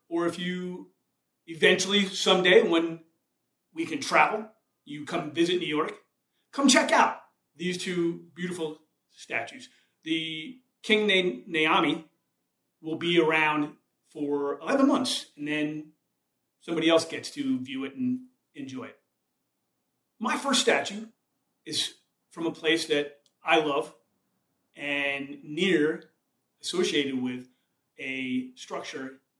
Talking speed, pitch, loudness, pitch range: 120 wpm, 170 Hz, -26 LUFS, 155-220 Hz